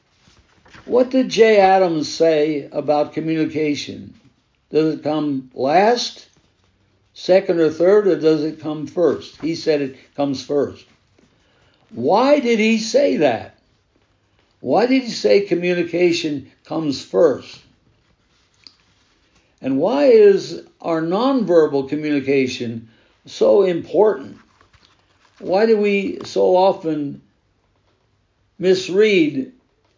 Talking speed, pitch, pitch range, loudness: 100 wpm, 155 Hz, 125-190 Hz, -17 LUFS